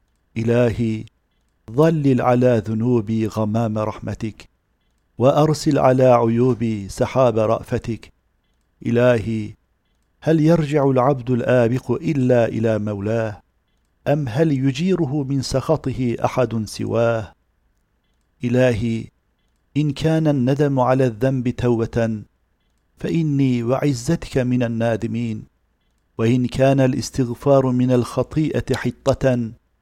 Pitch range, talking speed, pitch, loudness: 110-130 Hz, 85 wpm, 120 Hz, -19 LUFS